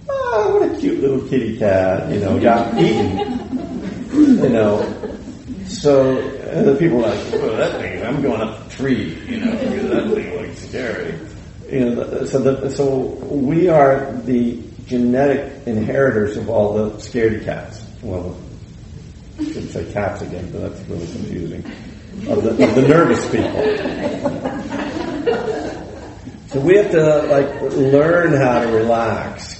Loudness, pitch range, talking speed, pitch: -17 LUFS, 110-150 Hz, 150 wpm, 125 Hz